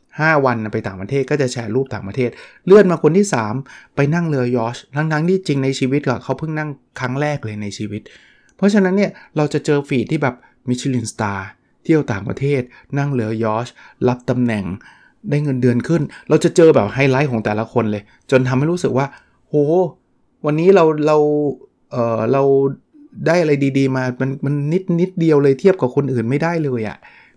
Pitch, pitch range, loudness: 135 Hz, 125-155 Hz, -17 LUFS